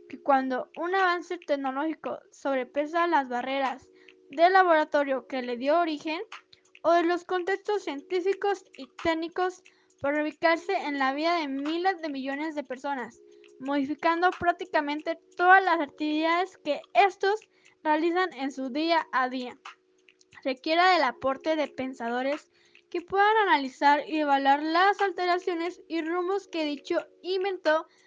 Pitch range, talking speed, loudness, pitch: 285-370 Hz, 135 wpm, -27 LUFS, 325 Hz